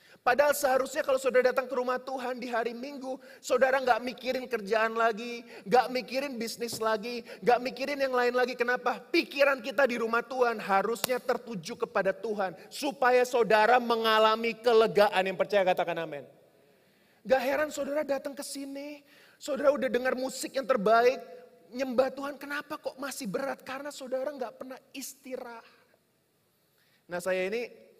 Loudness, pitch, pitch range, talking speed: -28 LUFS, 250 Hz, 230-270 Hz, 150 wpm